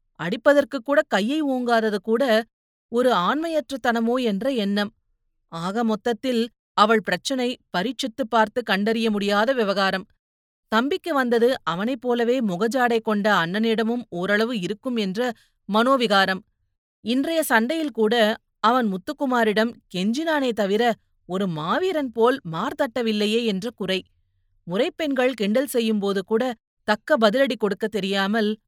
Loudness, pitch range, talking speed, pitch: -22 LUFS, 205-255 Hz, 110 wpm, 225 Hz